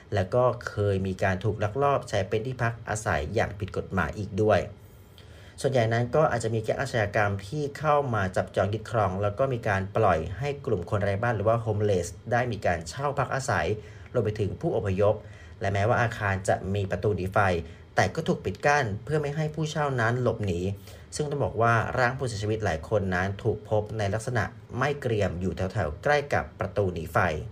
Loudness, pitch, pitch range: -27 LUFS, 105 Hz, 100-120 Hz